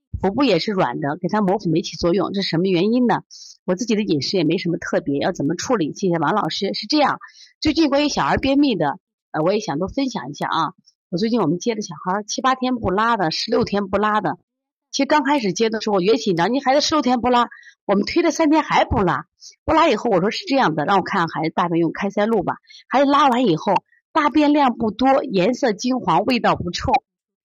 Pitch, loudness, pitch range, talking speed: 215 Hz, -19 LUFS, 180-265 Hz, 345 characters per minute